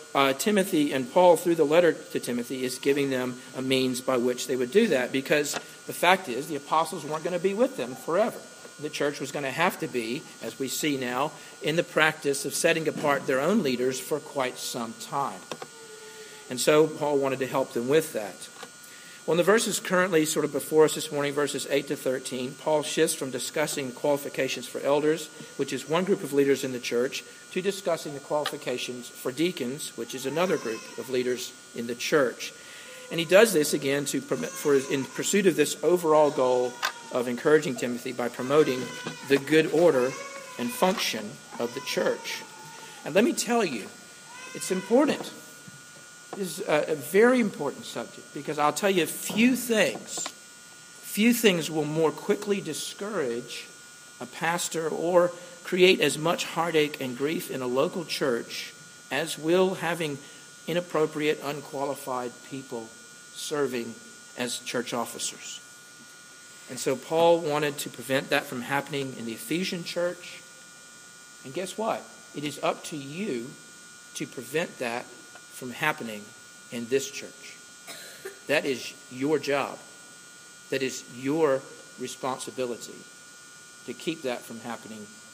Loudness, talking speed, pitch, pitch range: -27 LUFS, 160 wpm, 145 Hz, 130-165 Hz